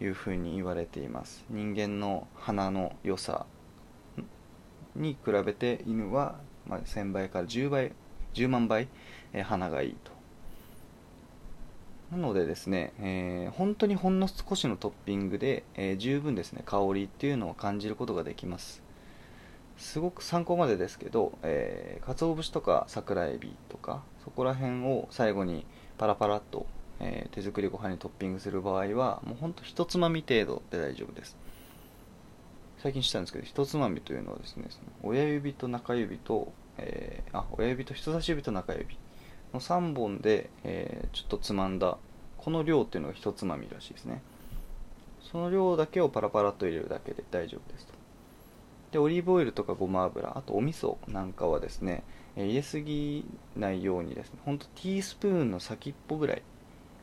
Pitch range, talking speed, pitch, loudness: 95-145 Hz, 325 characters per minute, 110 Hz, -32 LUFS